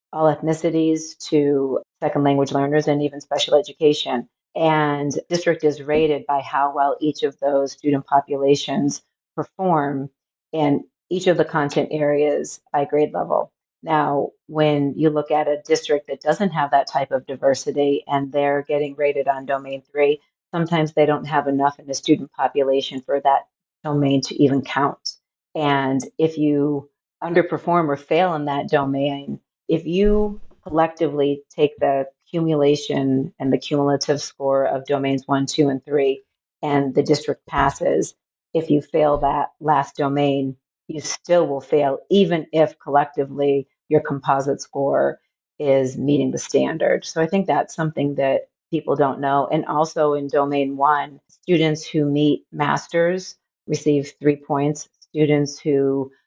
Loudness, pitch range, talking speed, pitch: -20 LUFS, 140-155 Hz, 150 wpm, 145 Hz